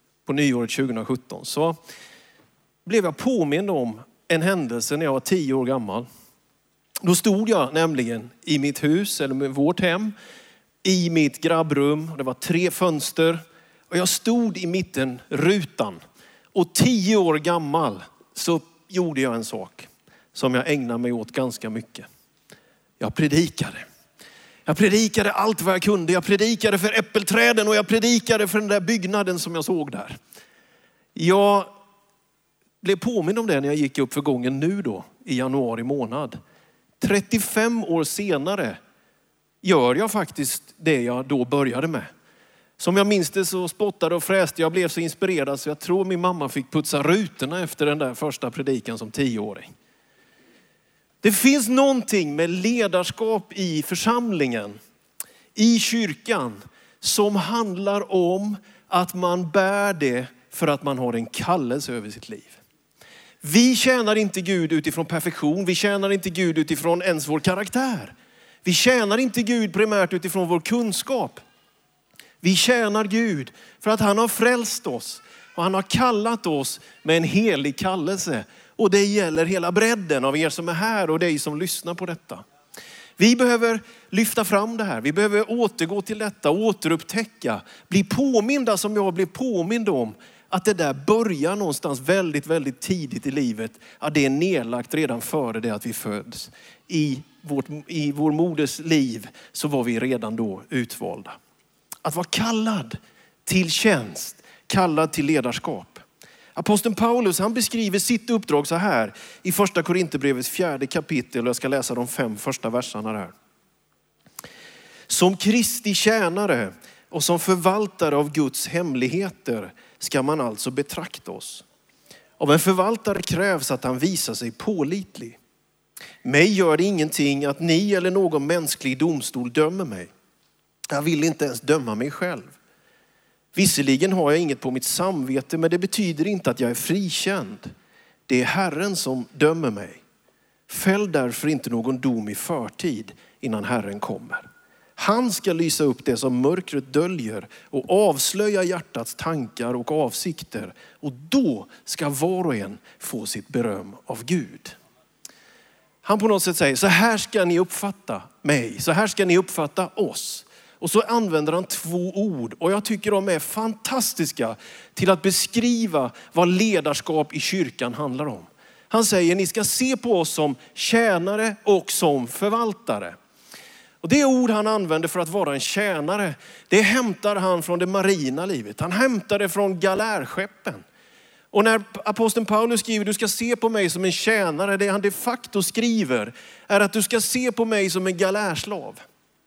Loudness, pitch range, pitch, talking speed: -22 LUFS, 150-210 Hz, 180 Hz, 155 wpm